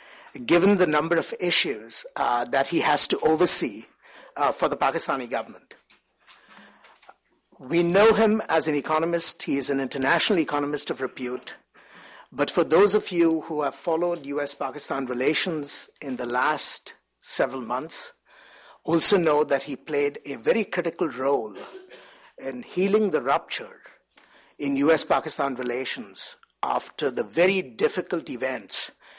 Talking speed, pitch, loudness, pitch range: 135 wpm, 165 Hz, -23 LUFS, 145-200 Hz